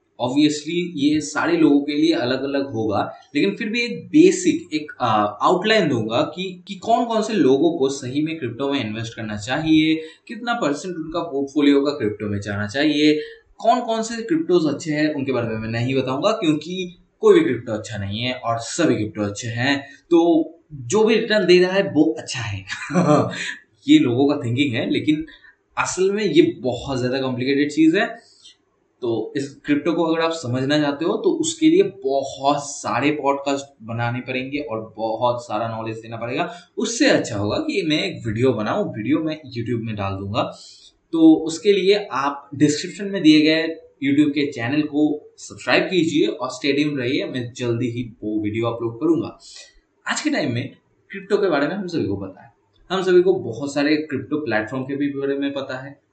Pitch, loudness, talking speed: 150 Hz, -20 LUFS, 185 wpm